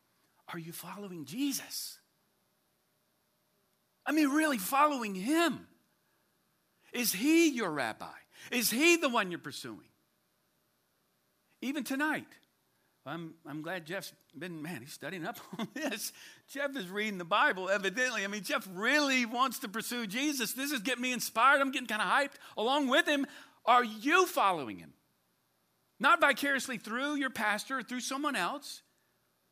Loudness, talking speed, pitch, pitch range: -31 LUFS, 145 wpm, 250 Hz, 205-285 Hz